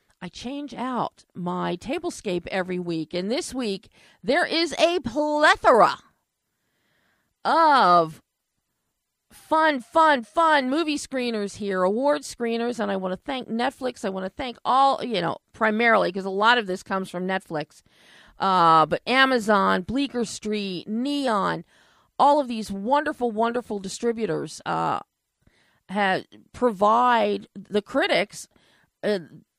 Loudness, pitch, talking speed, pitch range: -23 LUFS, 230 Hz, 130 wpm, 190-270 Hz